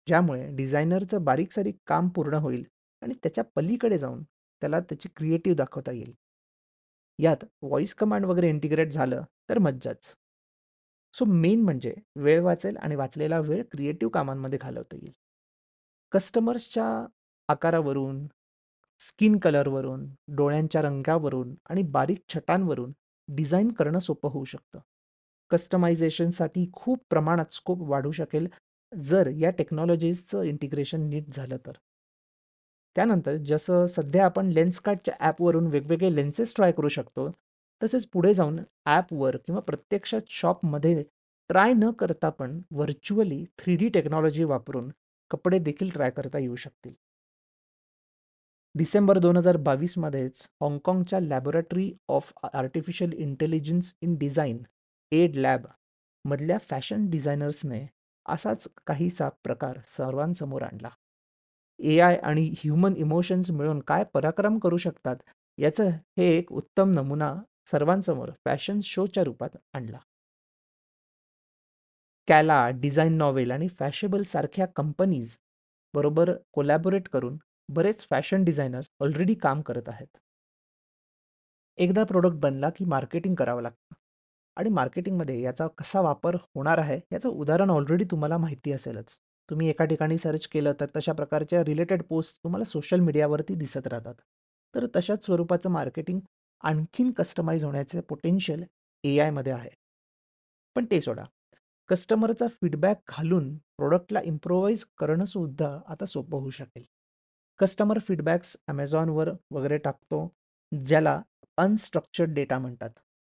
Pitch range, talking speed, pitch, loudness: 140-180 Hz, 120 wpm, 160 Hz, -27 LUFS